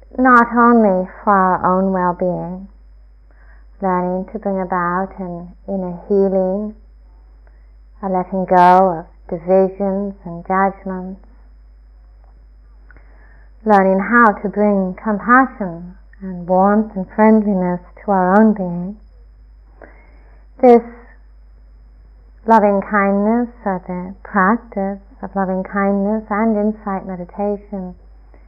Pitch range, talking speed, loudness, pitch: 175-205 Hz, 95 wpm, -16 LUFS, 190 Hz